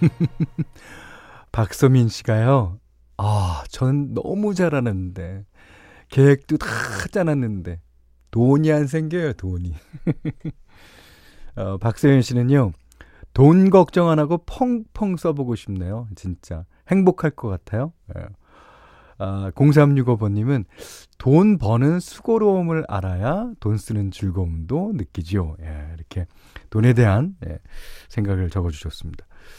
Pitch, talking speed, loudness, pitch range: 115 Hz, 220 characters per minute, -20 LUFS, 95-155 Hz